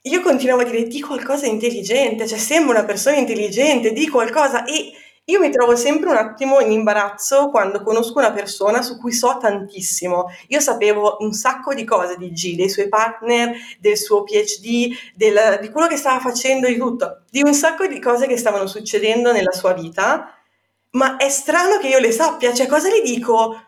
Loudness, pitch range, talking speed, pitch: -17 LUFS, 215-280 Hz, 195 wpm, 240 Hz